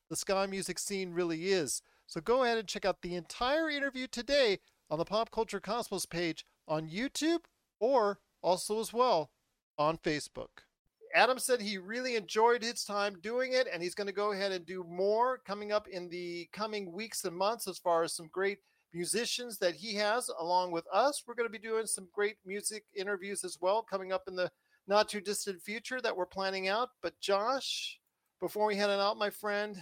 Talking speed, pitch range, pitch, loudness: 200 wpm, 185-230 Hz, 205 Hz, -33 LUFS